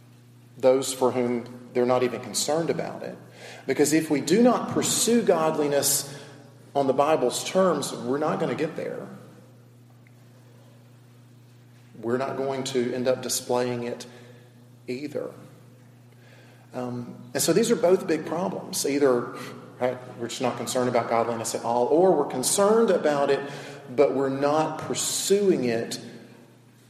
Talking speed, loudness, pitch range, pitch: 140 wpm, -24 LUFS, 120-140 Hz, 125 Hz